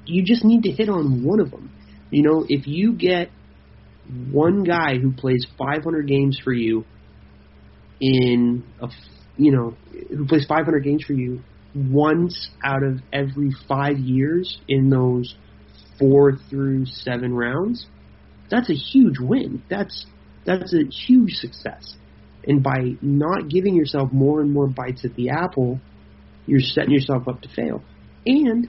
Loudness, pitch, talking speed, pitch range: -20 LUFS, 135 Hz, 150 wpm, 125-155 Hz